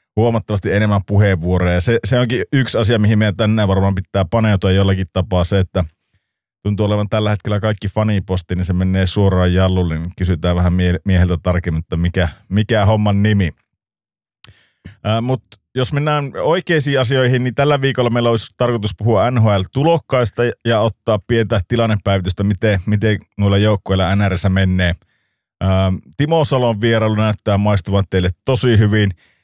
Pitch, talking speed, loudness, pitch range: 105 Hz, 145 wpm, -16 LUFS, 95-115 Hz